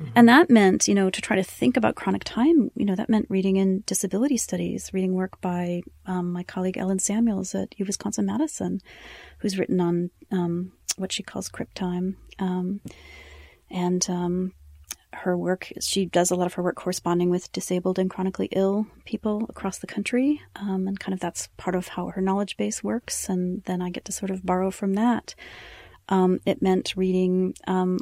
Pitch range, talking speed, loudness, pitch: 180-200 Hz, 190 wpm, -25 LUFS, 190 Hz